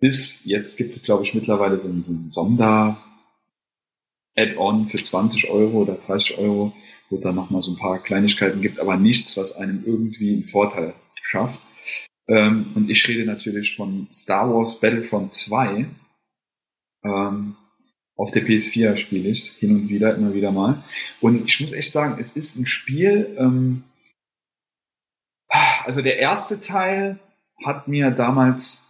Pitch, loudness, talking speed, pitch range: 110 Hz, -19 LUFS, 155 wpm, 100-130 Hz